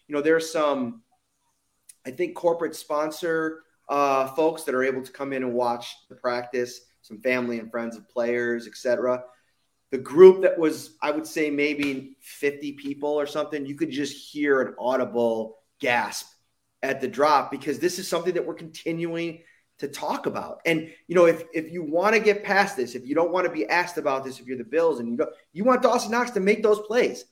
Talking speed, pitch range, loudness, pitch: 205 wpm, 130-170 Hz, -24 LUFS, 150 Hz